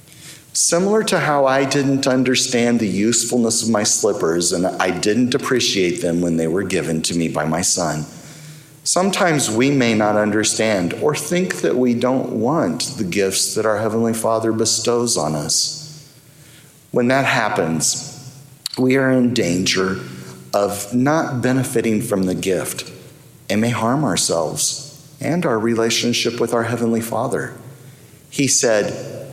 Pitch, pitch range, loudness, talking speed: 120 Hz, 105-140 Hz, -18 LUFS, 145 wpm